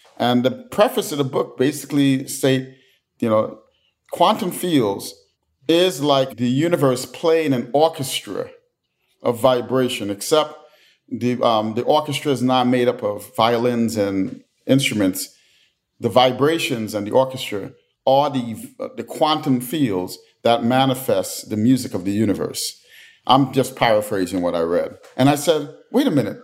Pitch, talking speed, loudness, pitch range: 130 Hz, 145 wpm, -20 LUFS, 120-145 Hz